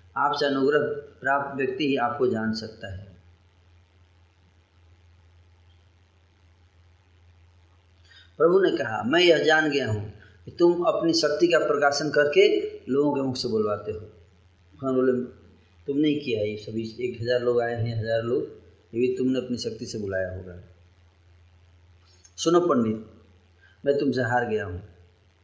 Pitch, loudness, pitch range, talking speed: 105 Hz, -24 LUFS, 90-130 Hz, 135 wpm